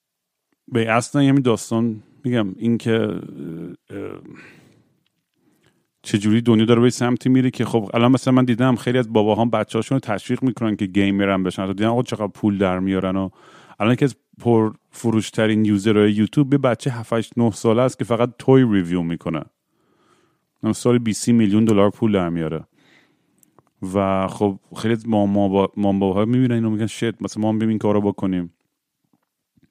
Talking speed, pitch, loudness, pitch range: 175 wpm, 110 Hz, -19 LUFS, 100-120 Hz